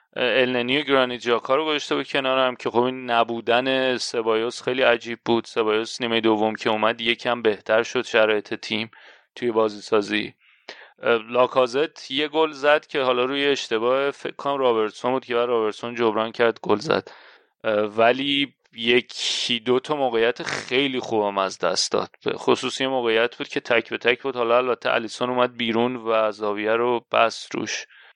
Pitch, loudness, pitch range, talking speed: 120 Hz, -22 LUFS, 115-130 Hz, 165 wpm